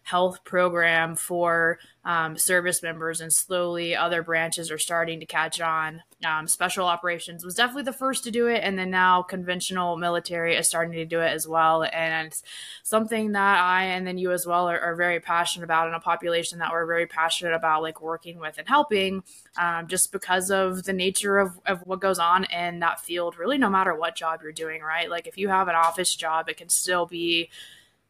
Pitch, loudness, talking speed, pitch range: 170 Hz, -24 LUFS, 205 wpm, 165-185 Hz